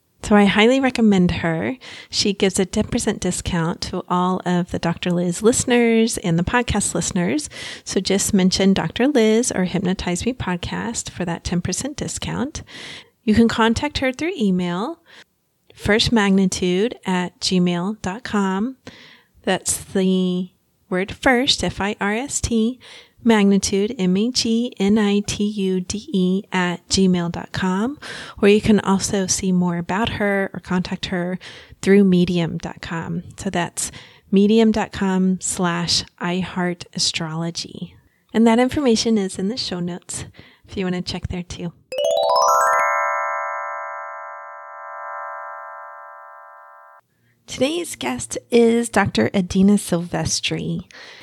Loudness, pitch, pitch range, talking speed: -20 LUFS, 185 Hz, 175-215 Hz, 115 wpm